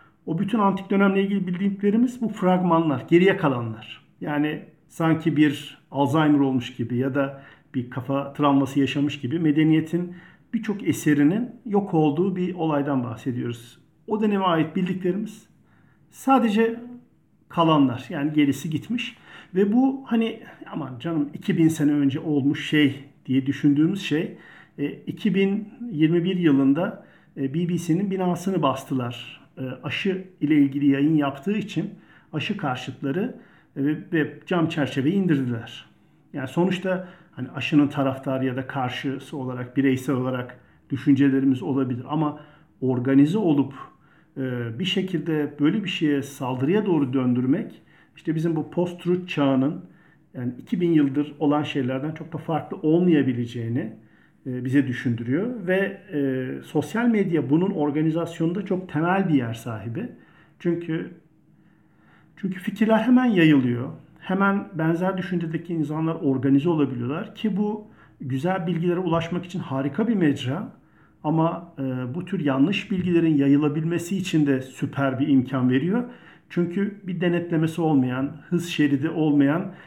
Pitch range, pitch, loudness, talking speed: 140-180 Hz, 155 Hz, -23 LUFS, 120 wpm